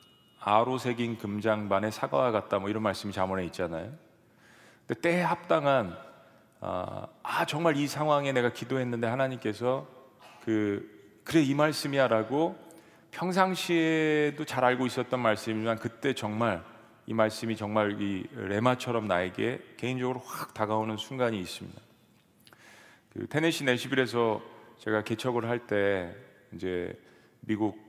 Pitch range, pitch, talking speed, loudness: 105-135 Hz, 120 Hz, 290 characters per minute, -29 LUFS